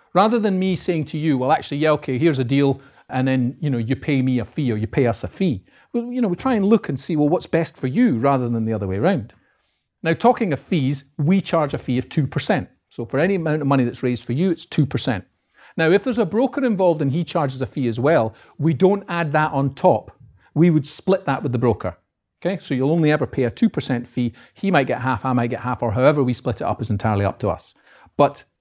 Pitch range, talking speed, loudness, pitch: 125-170 Hz, 260 wpm, -20 LUFS, 140 Hz